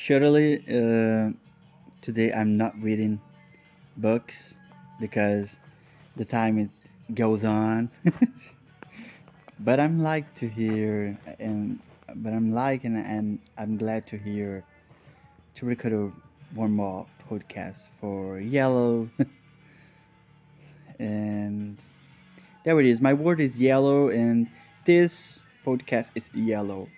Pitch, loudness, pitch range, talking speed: 120 Hz, -26 LUFS, 110-150 Hz, 105 wpm